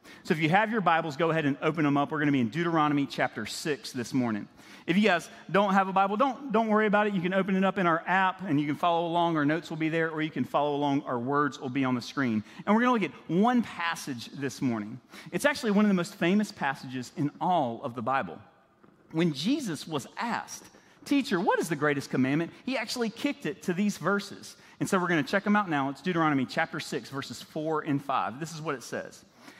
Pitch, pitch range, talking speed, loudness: 165 Hz, 140-195 Hz, 255 wpm, -28 LUFS